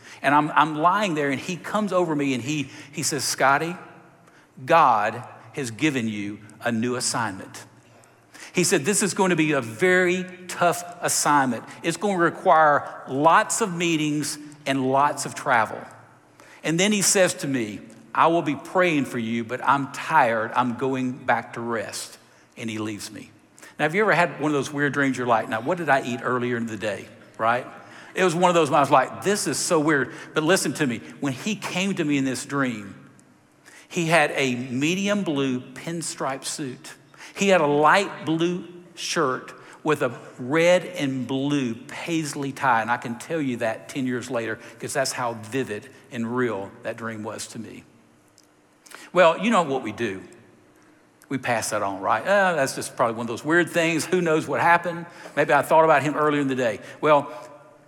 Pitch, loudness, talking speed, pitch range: 145 Hz, -23 LUFS, 195 wpm, 125-170 Hz